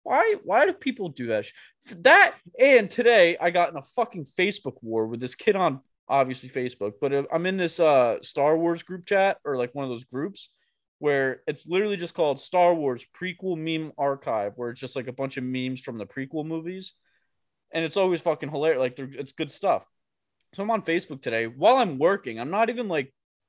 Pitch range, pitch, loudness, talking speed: 130-185 Hz, 155 Hz, -24 LUFS, 205 wpm